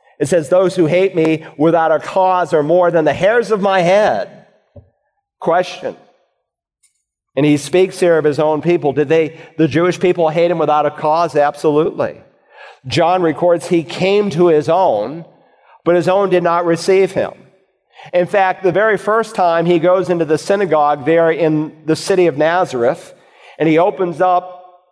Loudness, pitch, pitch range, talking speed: -14 LUFS, 170 Hz, 155-185 Hz, 175 wpm